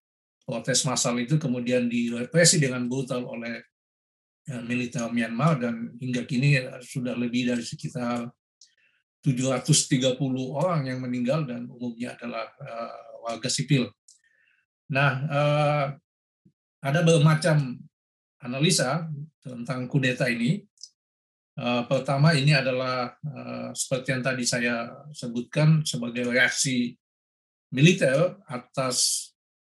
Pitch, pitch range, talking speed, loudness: 130 Hz, 120-145 Hz, 100 wpm, -25 LUFS